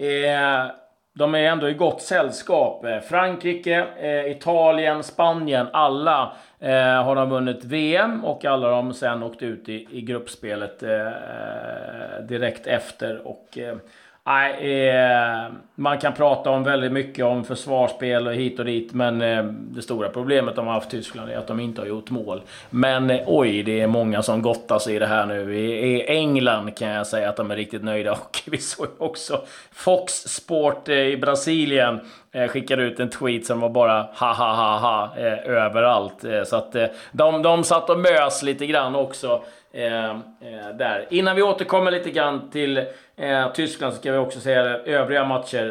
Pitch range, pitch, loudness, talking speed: 115-145 Hz, 130 Hz, -22 LUFS, 165 wpm